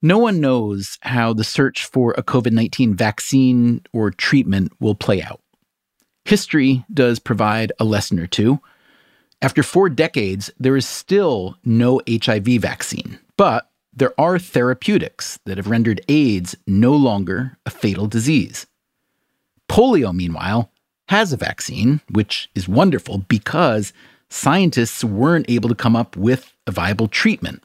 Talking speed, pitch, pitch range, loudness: 140 wpm, 120 Hz, 105-135 Hz, -18 LUFS